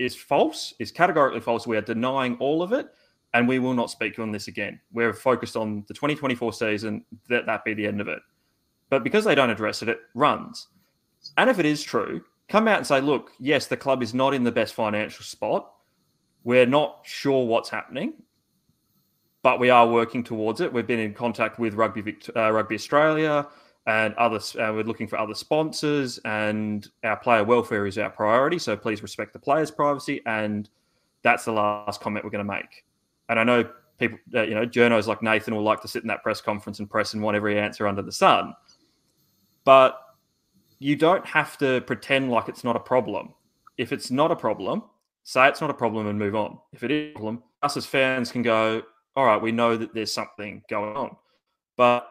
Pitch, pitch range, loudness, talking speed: 115 Hz, 110-130 Hz, -24 LUFS, 210 wpm